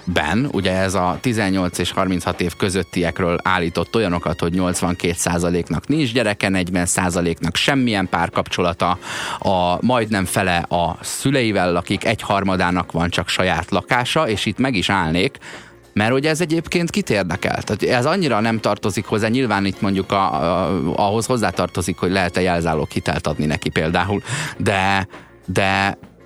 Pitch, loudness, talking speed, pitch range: 95 Hz, -19 LUFS, 145 wpm, 90-110 Hz